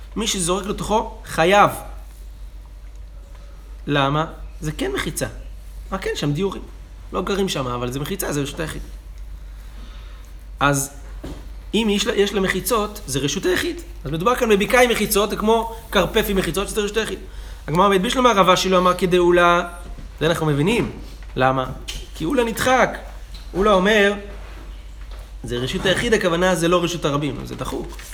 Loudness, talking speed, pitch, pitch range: -20 LUFS, 150 wpm, 175 Hz, 120-200 Hz